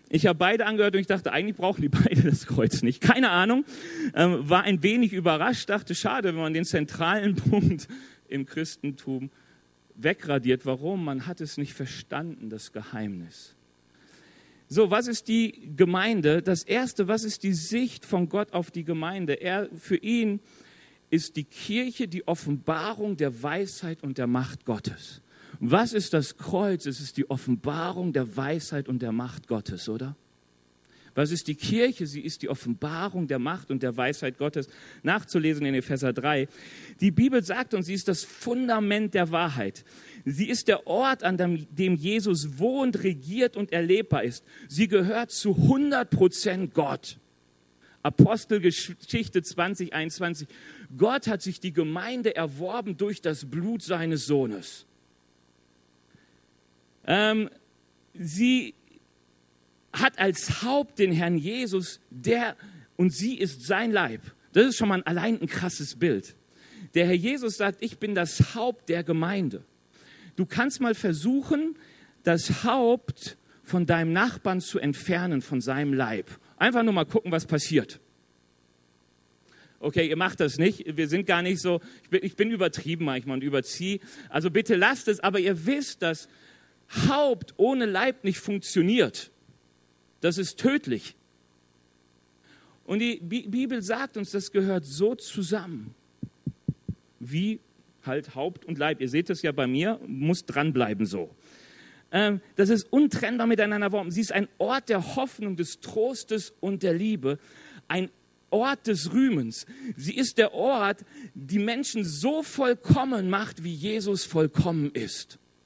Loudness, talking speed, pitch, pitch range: -26 LUFS, 150 wpm, 175 Hz, 145-210 Hz